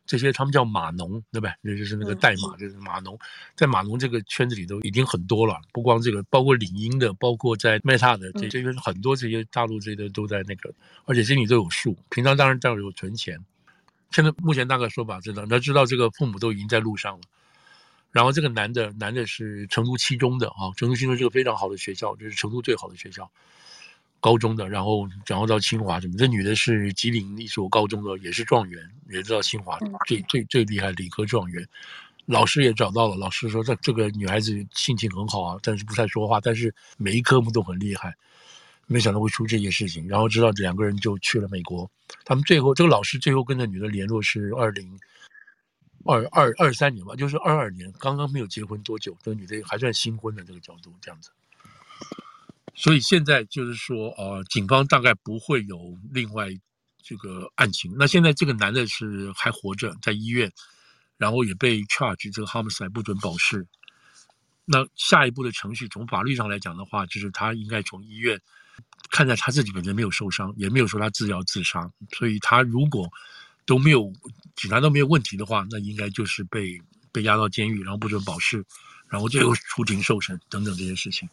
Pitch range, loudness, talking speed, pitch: 100-125 Hz, -23 LUFS, 325 characters per minute, 110 Hz